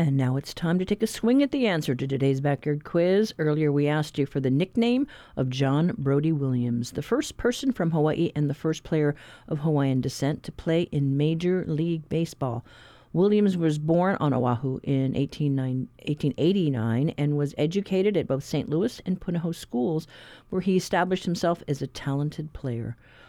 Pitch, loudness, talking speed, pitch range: 150 Hz, -26 LUFS, 180 wpm, 135-175 Hz